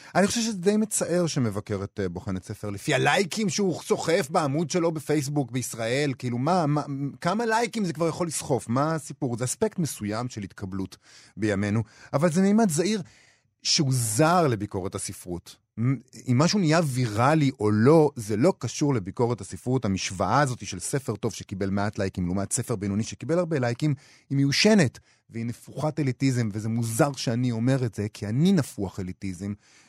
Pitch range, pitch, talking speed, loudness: 105-160 Hz, 130 Hz, 165 wpm, -26 LUFS